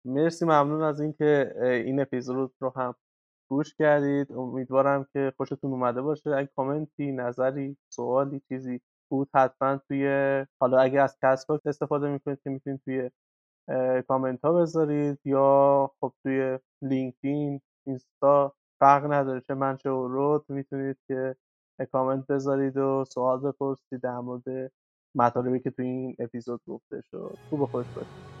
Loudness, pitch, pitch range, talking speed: -27 LUFS, 135 Hz, 130-140 Hz, 145 wpm